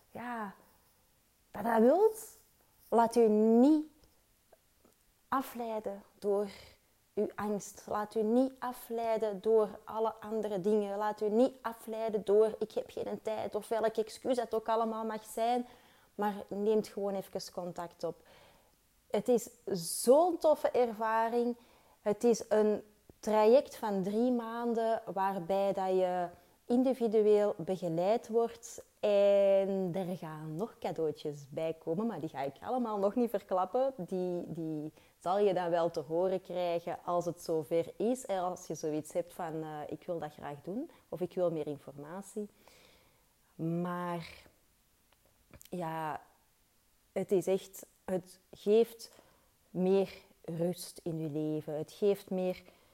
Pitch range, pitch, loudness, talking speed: 175-225 Hz, 205 Hz, -33 LUFS, 135 wpm